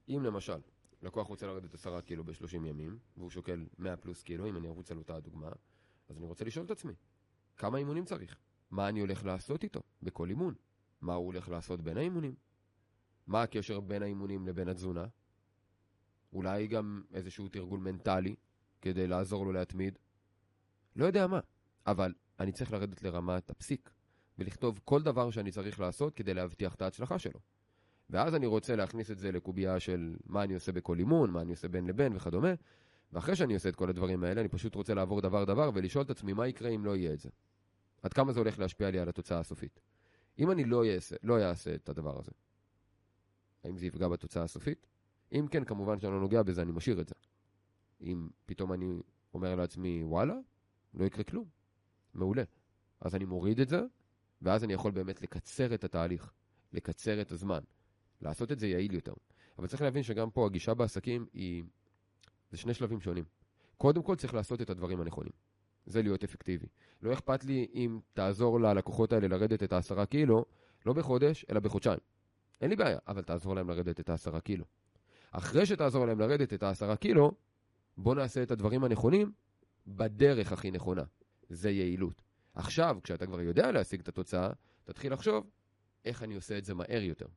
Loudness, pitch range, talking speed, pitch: -35 LUFS, 90-115 Hz, 180 wpm, 100 Hz